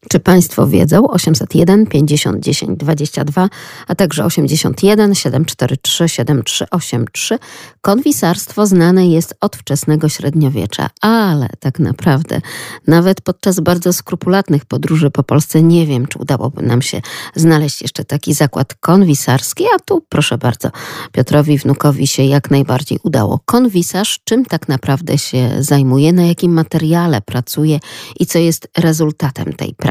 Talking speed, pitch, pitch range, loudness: 130 wpm, 155 Hz, 140-175 Hz, -13 LUFS